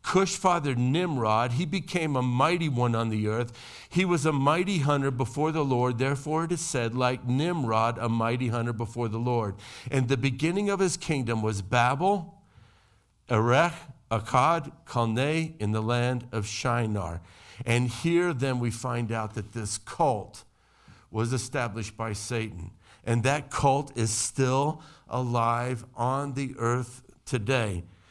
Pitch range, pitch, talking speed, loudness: 115-145 Hz, 125 Hz, 150 wpm, -27 LUFS